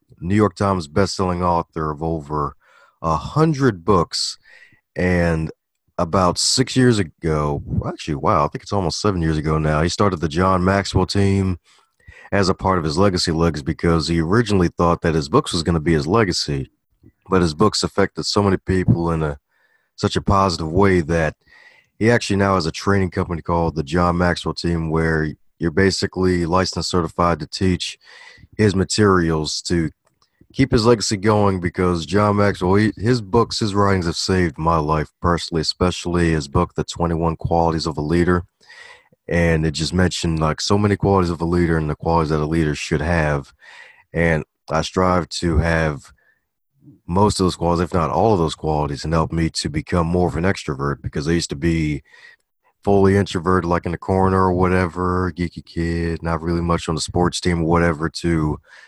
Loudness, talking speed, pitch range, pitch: -19 LUFS, 185 wpm, 80-95 Hz, 85 Hz